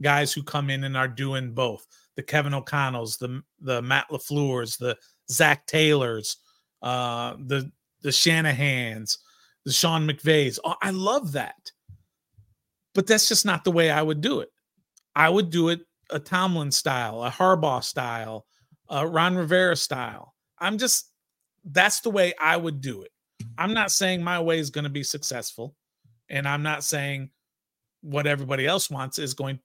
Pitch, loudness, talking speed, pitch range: 145 Hz, -24 LUFS, 170 wpm, 130-165 Hz